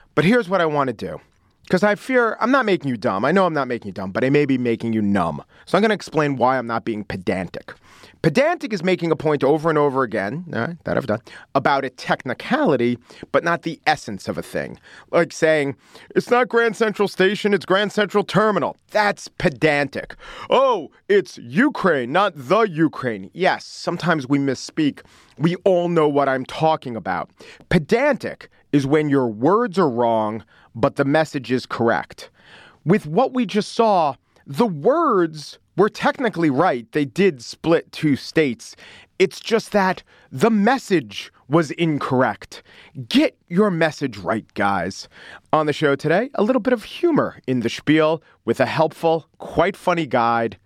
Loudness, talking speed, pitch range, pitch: -20 LUFS, 180 wpm, 130-205 Hz, 160 Hz